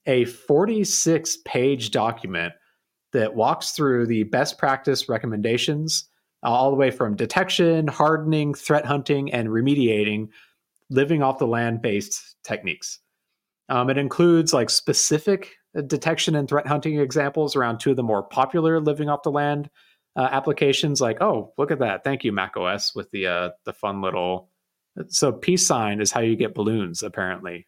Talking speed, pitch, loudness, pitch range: 160 wpm, 140 Hz, -22 LUFS, 115-155 Hz